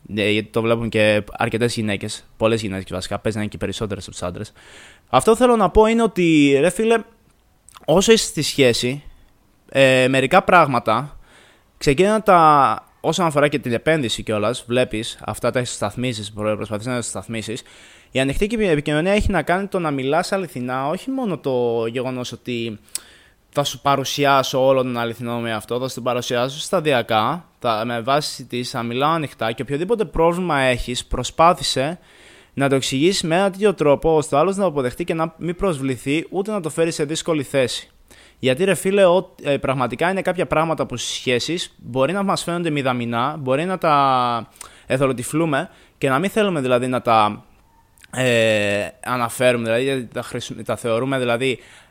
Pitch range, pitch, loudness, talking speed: 115-165 Hz, 130 Hz, -19 LUFS, 170 wpm